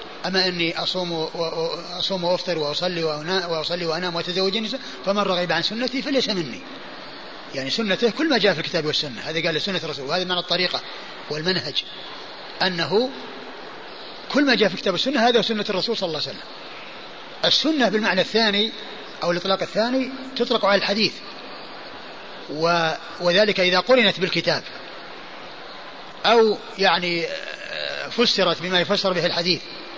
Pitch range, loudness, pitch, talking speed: 170-220 Hz, -21 LUFS, 185 Hz, 135 wpm